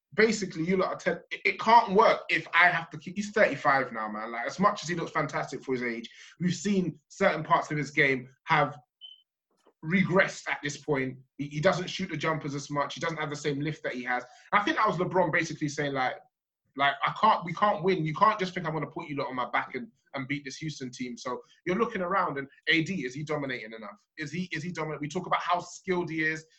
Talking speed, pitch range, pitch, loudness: 245 wpm, 140-185 Hz, 155 Hz, -28 LUFS